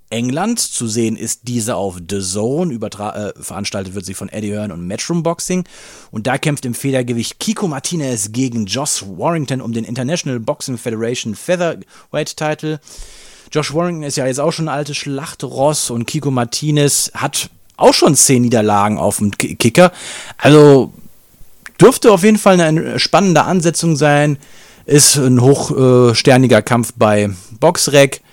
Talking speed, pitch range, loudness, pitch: 155 wpm, 115-155 Hz, -14 LUFS, 130 Hz